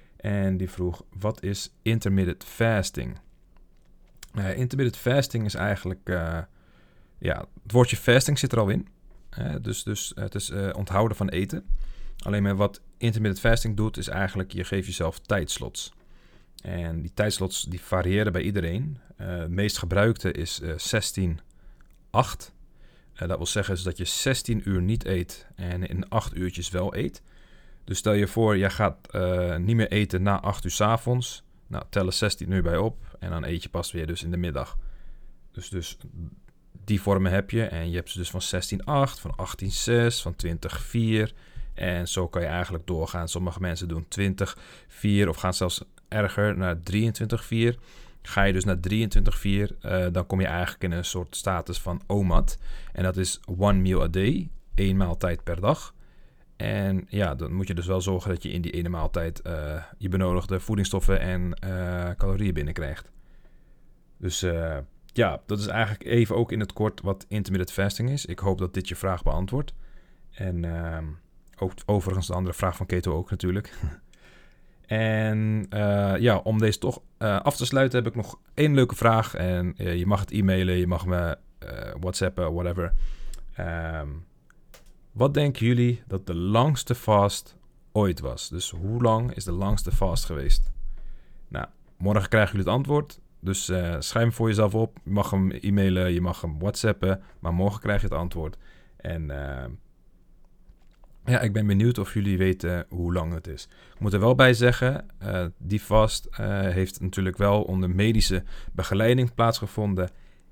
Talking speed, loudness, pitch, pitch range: 175 wpm, -26 LUFS, 95 Hz, 90-105 Hz